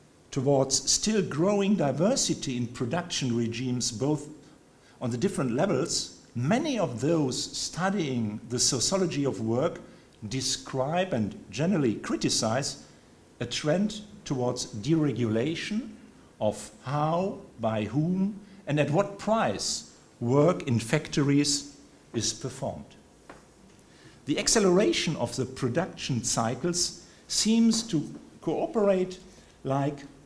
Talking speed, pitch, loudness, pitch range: 100 wpm, 145 Hz, -28 LUFS, 125-180 Hz